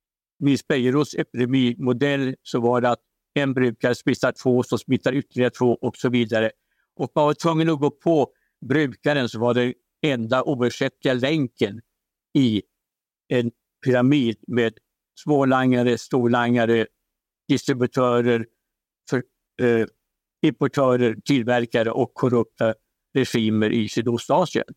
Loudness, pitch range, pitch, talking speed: -22 LUFS, 120-135 Hz, 125 Hz, 115 wpm